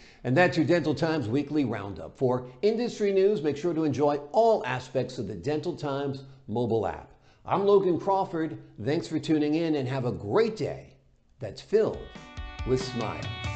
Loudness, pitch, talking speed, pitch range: -27 LUFS, 145 Hz, 170 wpm, 125-165 Hz